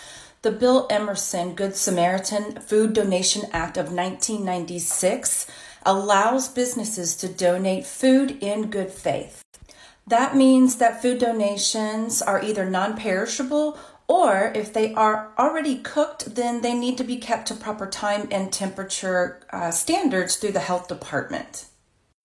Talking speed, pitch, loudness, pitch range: 135 wpm, 210 Hz, -22 LUFS, 190-240 Hz